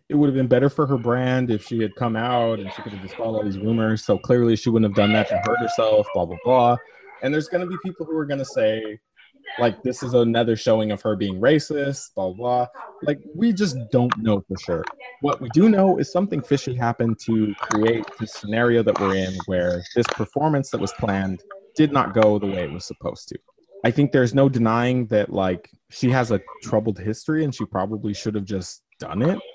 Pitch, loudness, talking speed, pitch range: 115 Hz, -22 LUFS, 230 wpm, 105-135 Hz